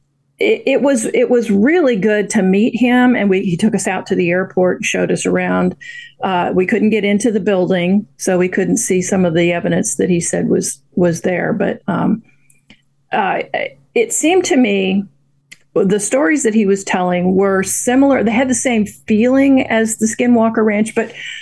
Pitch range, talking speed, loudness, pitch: 185-245 Hz, 195 wpm, -15 LUFS, 210 Hz